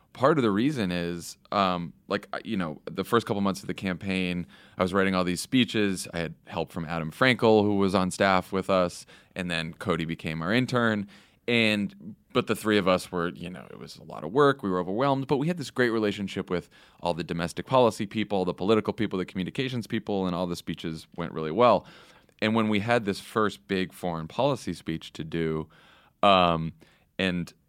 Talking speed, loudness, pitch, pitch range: 210 wpm, -27 LUFS, 95 Hz, 85-110 Hz